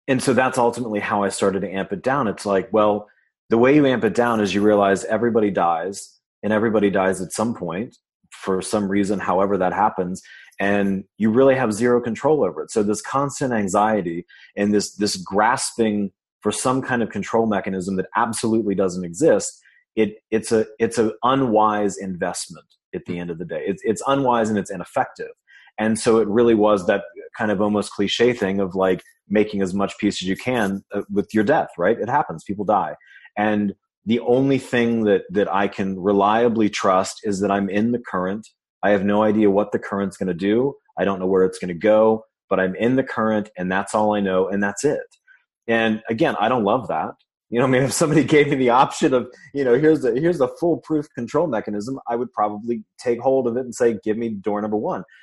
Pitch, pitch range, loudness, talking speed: 105 Hz, 100-120 Hz, -20 LUFS, 215 wpm